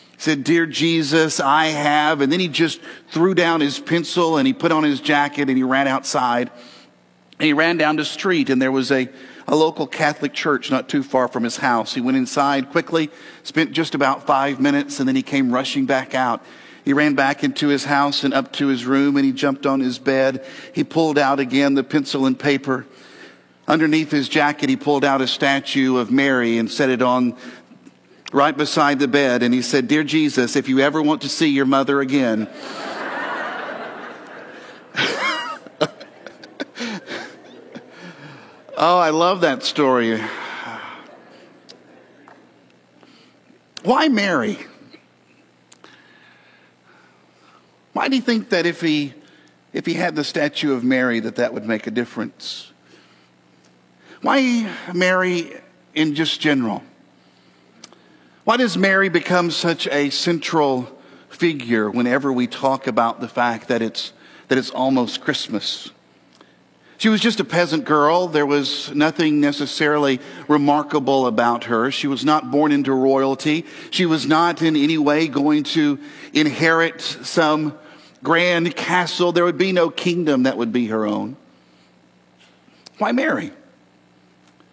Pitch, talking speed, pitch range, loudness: 145 Hz, 150 wpm, 130-160 Hz, -19 LUFS